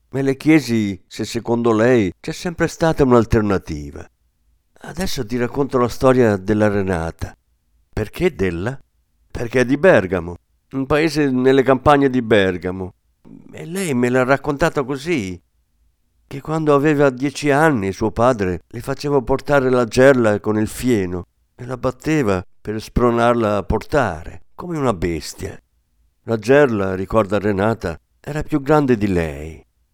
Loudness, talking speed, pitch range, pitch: -18 LUFS, 140 wpm, 90-140 Hz, 115 Hz